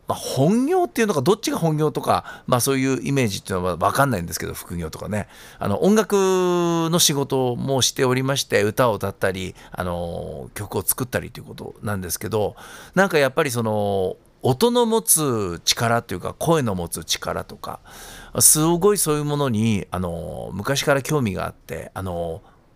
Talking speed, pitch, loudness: 355 characters per minute, 130 Hz, -21 LUFS